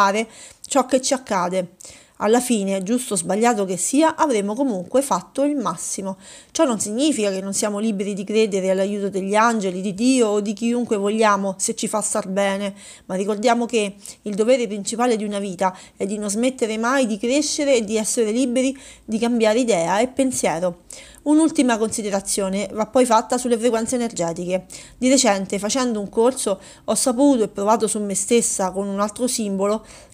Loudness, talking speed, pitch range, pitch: -20 LUFS, 175 wpm, 200-245 Hz, 220 Hz